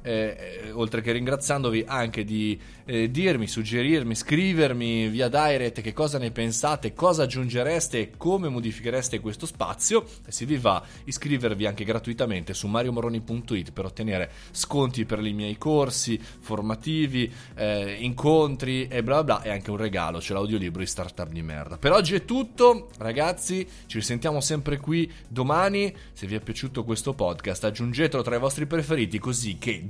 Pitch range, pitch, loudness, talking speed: 110-145 Hz, 120 Hz, -26 LUFS, 165 wpm